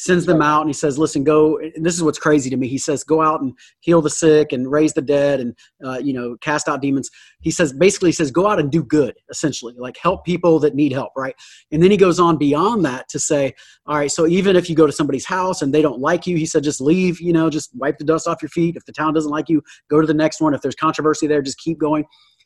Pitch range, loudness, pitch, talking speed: 145-165 Hz, -18 LUFS, 155 Hz, 285 wpm